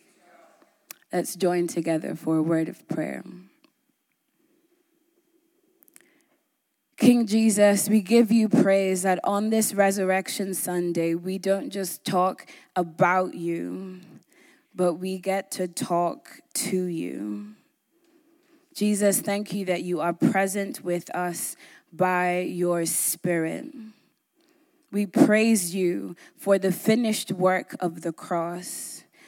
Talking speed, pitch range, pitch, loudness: 110 wpm, 180-275 Hz, 195 Hz, -25 LUFS